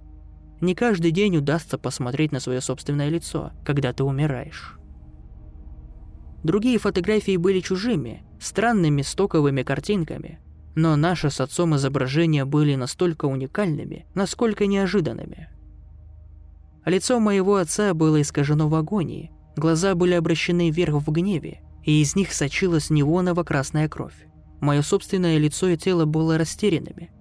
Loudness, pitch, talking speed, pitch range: -22 LUFS, 155 Hz, 120 wpm, 130-180 Hz